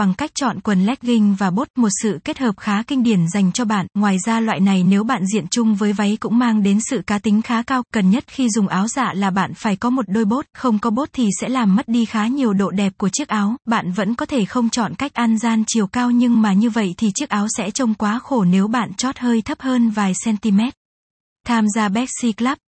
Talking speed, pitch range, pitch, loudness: 255 wpm, 205-245 Hz, 225 Hz, -18 LUFS